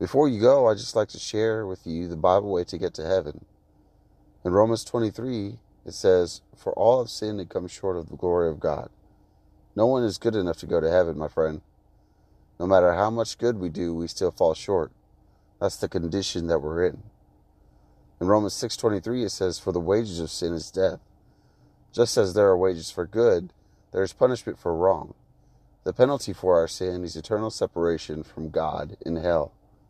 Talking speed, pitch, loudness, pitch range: 195 wpm, 90 Hz, -25 LUFS, 80-105 Hz